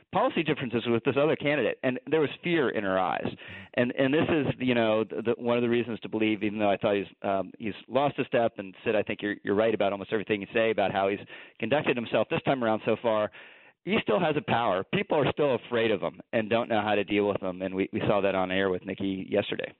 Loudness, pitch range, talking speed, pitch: -28 LUFS, 100-120 Hz, 265 wpm, 110 Hz